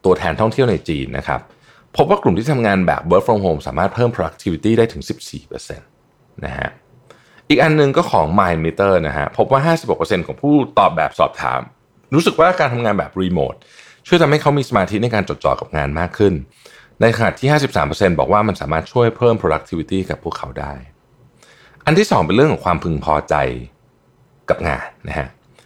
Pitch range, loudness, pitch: 80-120 Hz, -17 LUFS, 95 Hz